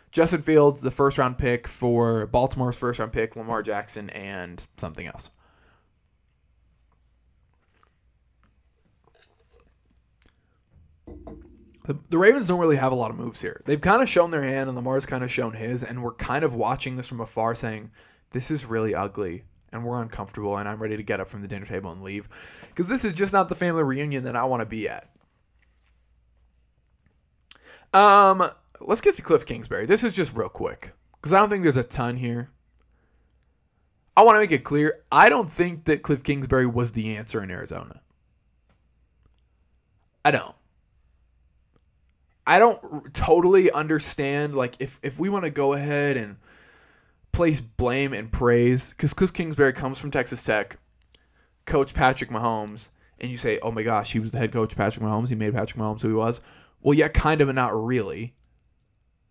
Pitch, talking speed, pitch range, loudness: 120 Hz, 175 wpm, 100-145 Hz, -23 LUFS